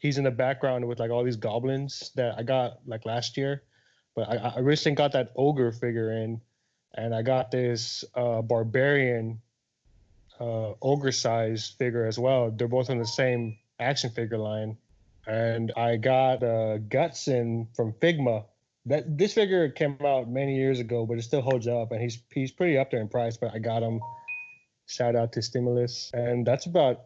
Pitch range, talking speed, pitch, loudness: 115-135 Hz, 185 wpm, 120 Hz, -27 LUFS